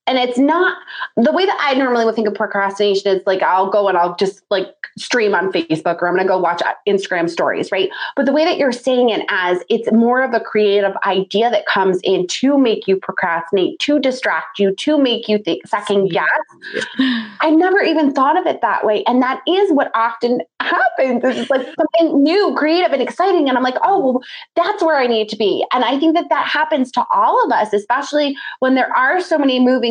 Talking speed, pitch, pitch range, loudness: 220 wpm, 250 Hz, 200-305 Hz, -16 LUFS